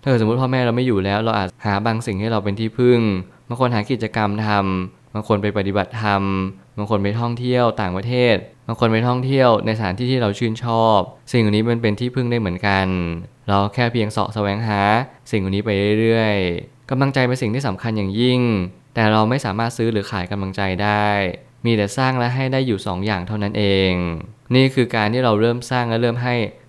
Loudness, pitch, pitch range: -19 LUFS, 110 Hz, 100-125 Hz